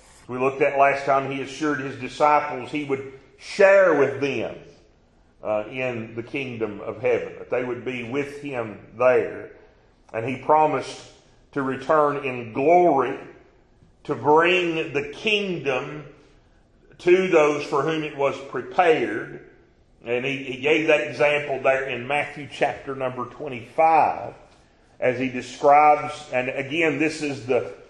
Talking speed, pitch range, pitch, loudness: 140 wpm, 130-150 Hz, 140 Hz, -22 LUFS